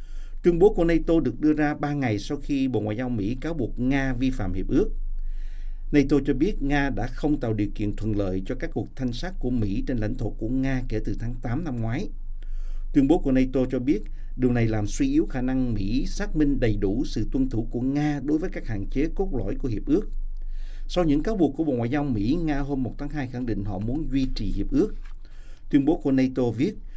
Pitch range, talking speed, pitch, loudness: 110-145 Hz, 245 wpm, 130 Hz, -26 LUFS